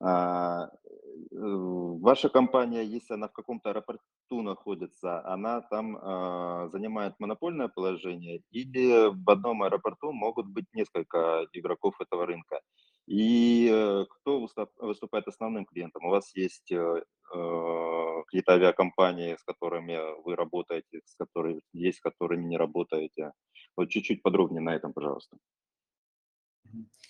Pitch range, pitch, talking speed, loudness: 85-110 Hz, 95 Hz, 110 wpm, -29 LUFS